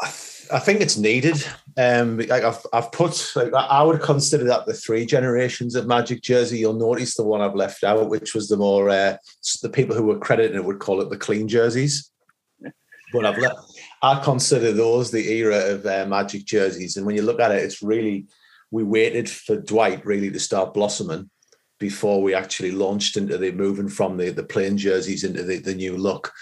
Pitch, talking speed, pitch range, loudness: 110 Hz, 200 wpm, 100-125 Hz, -21 LUFS